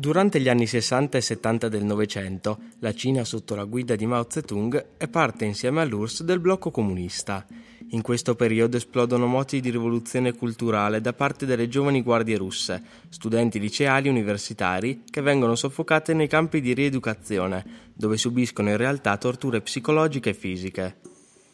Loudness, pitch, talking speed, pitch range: -24 LUFS, 120 Hz, 155 wpm, 110-135 Hz